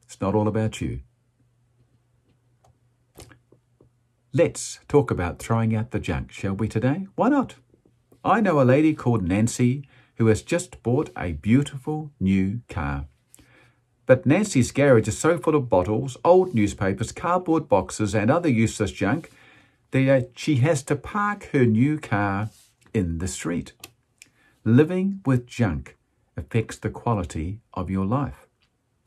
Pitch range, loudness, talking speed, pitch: 110-140 Hz, -23 LUFS, 140 wpm, 120 Hz